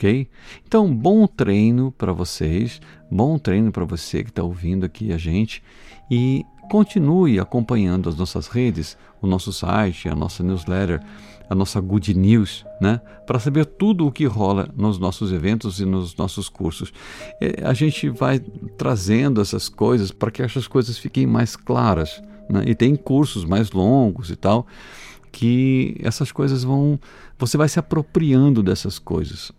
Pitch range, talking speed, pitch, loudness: 95-130 Hz, 155 wpm, 110 Hz, -20 LUFS